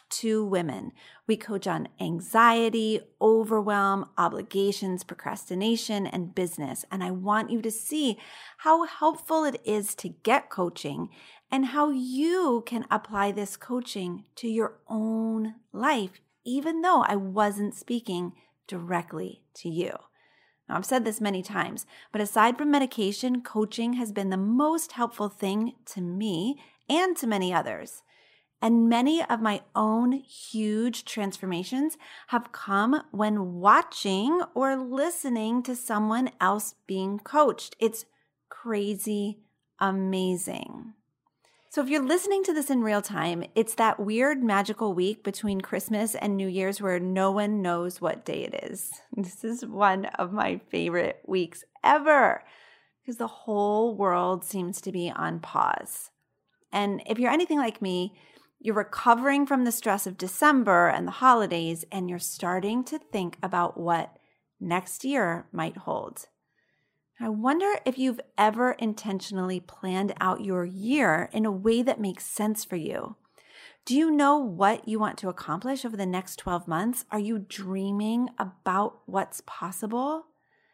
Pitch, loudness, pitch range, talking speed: 215 Hz, -27 LUFS, 190-250 Hz, 145 wpm